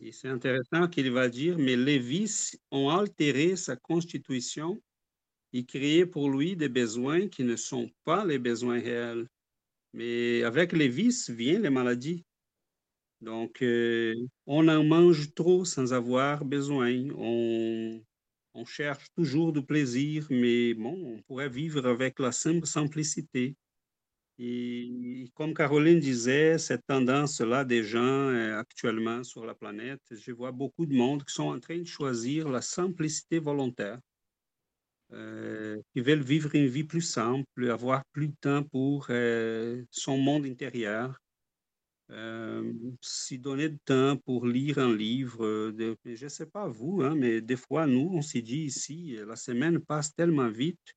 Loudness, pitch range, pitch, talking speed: -29 LUFS, 120-150 Hz, 130 Hz, 150 wpm